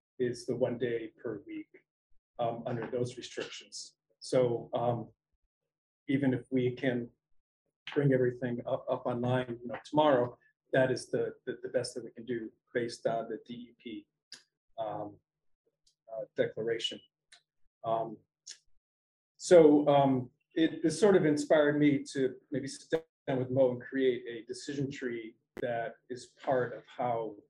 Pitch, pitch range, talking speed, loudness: 130 Hz, 120-150 Hz, 145 wpm, -32 LUFS